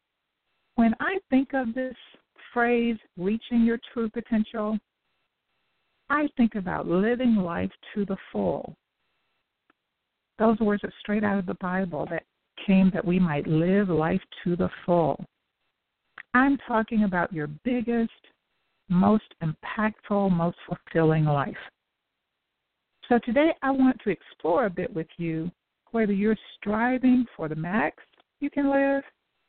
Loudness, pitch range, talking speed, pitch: -26 LUFS, 180-240 Hz, 130 wpm, 215 Hz